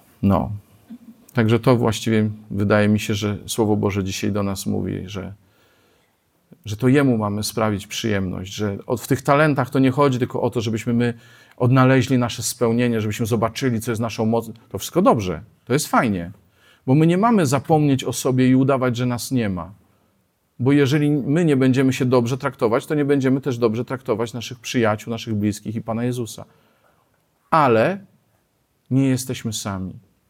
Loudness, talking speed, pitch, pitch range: -20 LUFS, 170 wpm, 120 Hz, 105-130 Hz